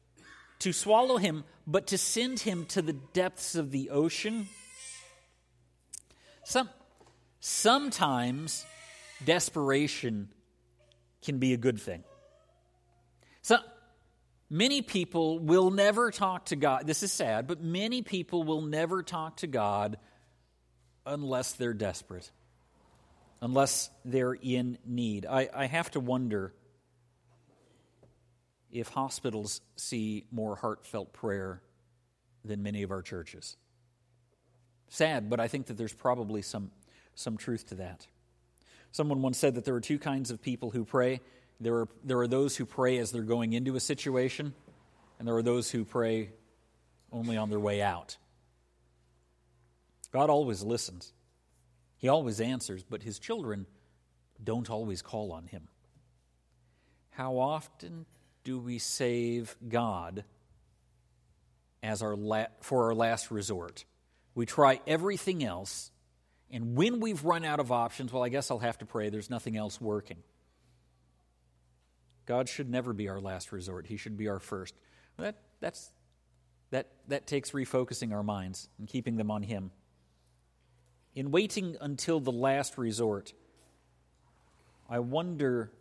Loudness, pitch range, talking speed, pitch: -32 LUFS, 95-140 Hz, 135 wpm, 120 Hz